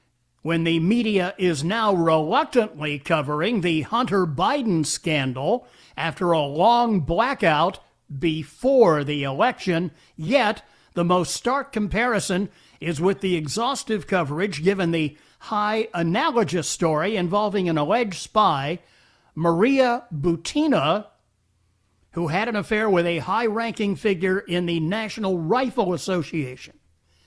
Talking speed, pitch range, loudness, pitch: 115 wpm, 160-215 Hz, -22 LUFS, 180 Hz